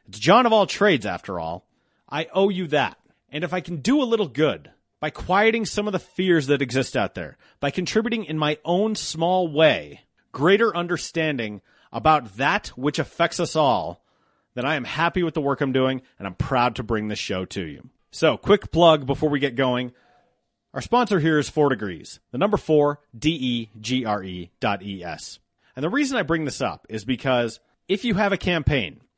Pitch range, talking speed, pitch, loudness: 130-180 Hz, 205 wpm, 150 Hz, -22 LUFS